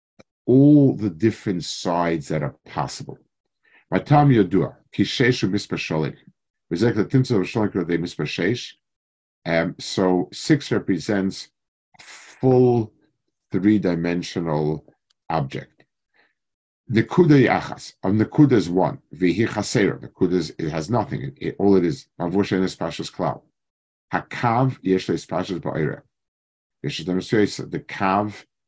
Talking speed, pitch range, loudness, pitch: 120 wpm, 90-120 Hz, -21 LUFS, 100 Hz